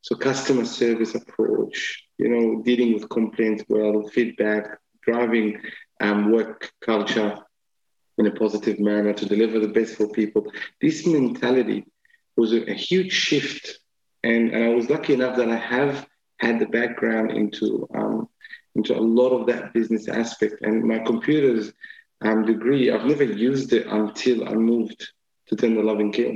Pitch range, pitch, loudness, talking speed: 110-125 Hz, 115 Hz, -22 LUFS, 155 wpm